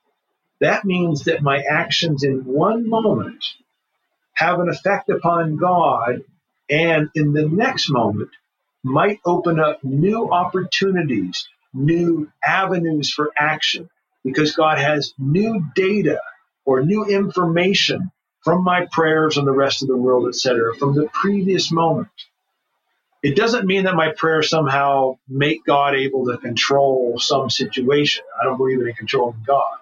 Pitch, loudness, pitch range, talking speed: 155 Hz, -18 LUFS, 135-180 Hz, 140 wpm